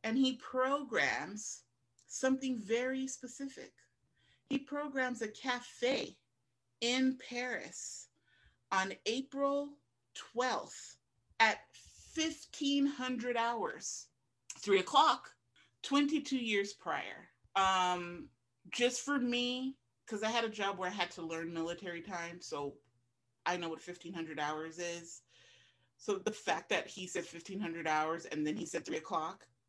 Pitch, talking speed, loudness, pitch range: 210 Hz, 120 wpm, -36 LUFS, 165-260 Hz